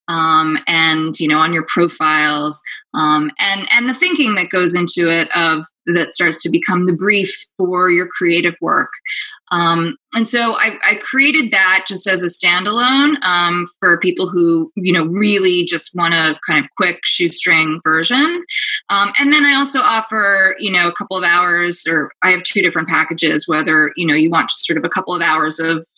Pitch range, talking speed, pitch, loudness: 160-210 Hz, 195 wpm, 175 Hz, -14 LUFS